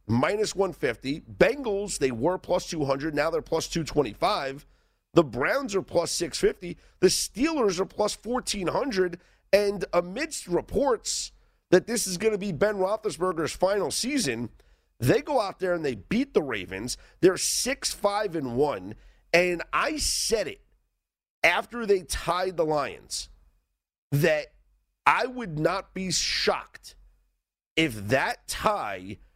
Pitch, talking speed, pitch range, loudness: 180 Hz, 130 wpm, 145-205 Hz, -26 LUFS